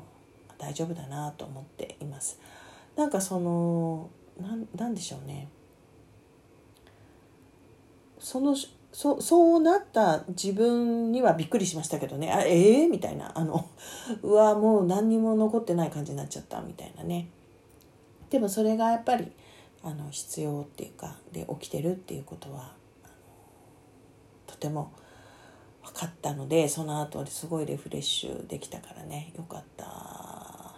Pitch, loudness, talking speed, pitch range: 165 Hz, -27 LUFS, 285 characters per minute, 150-220 Hz